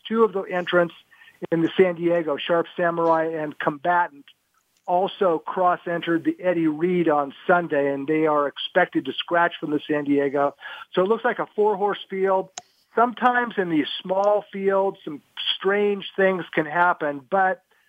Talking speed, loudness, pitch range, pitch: 165 wpm, -23 LUFS, 160-195 Hz, 175 Hz